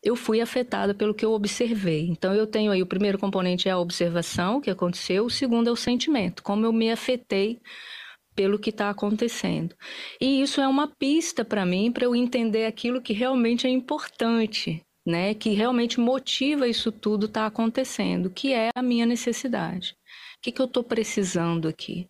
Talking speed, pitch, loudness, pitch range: 185 wpm, 225 Hz, -25 LUFS, 200-245 Hz